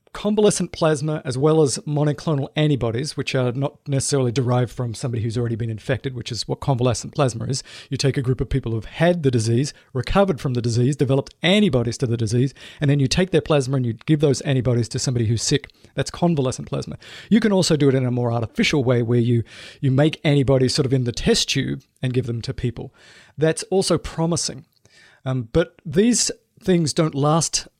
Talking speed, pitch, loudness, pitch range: 205 wpm, 135 Hz, -21 LUFS, 125-155 Hz